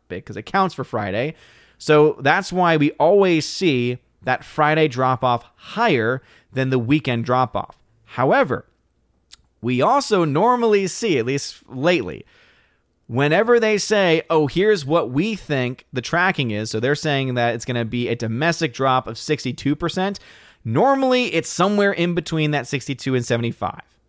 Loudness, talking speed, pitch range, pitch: -20 LUFS, 155 wpm, 125-175 Hz, 150 Hz